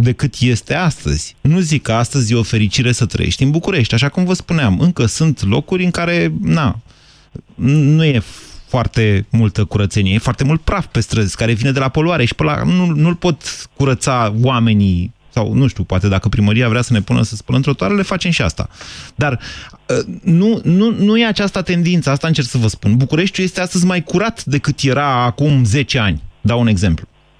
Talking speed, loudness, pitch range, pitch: 195 wpm, -15 LUFS, 115-165 Hz, 130 Hz